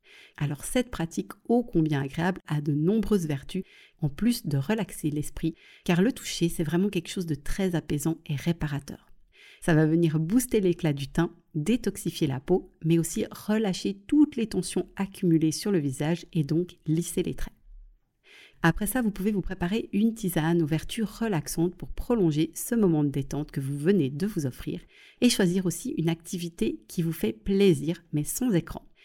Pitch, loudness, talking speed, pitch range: 170 Hz, -27 LUFS, 180 wpm, 160-200 Hz